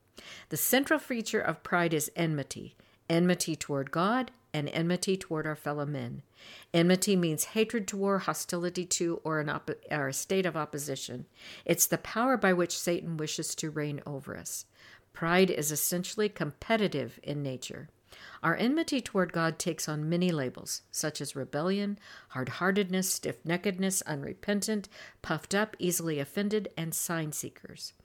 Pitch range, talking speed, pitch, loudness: 150-190 Hz, 150 wpm, 170 Hz, -31 LUFS